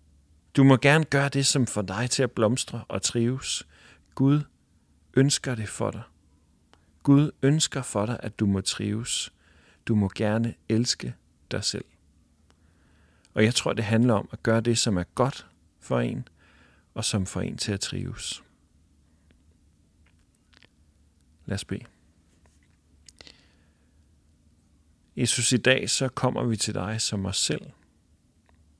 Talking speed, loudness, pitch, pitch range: 140 wpm, -25 LUFS, 95 Hz, 80-115 Hz